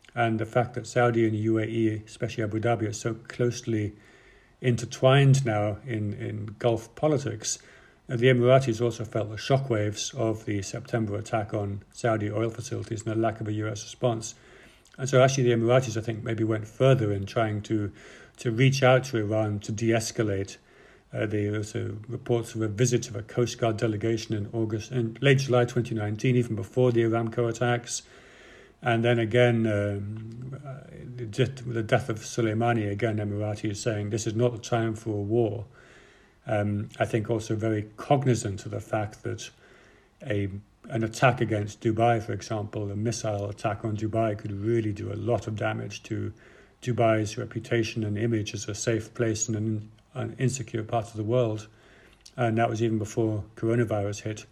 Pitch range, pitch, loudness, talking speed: 110-120 Hz, 115 Hz, -27 LUFS, 175 wpm